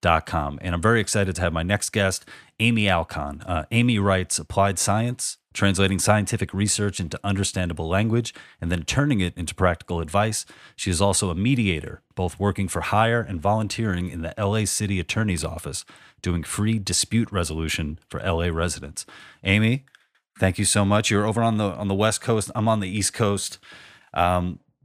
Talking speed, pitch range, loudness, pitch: 180 wpm, 90-105 Hz, -23 LUFS, 100 Hz